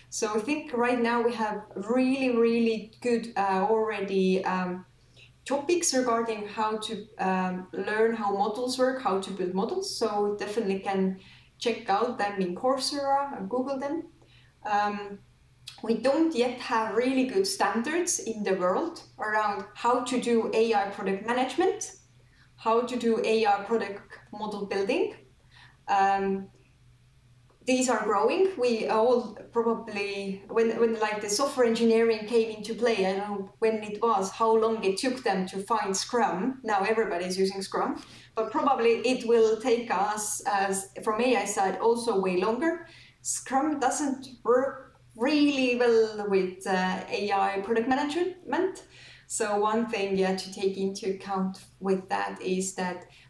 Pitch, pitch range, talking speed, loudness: 220 Hz, 195-245 Hz, 145 wpm, -27 LUFS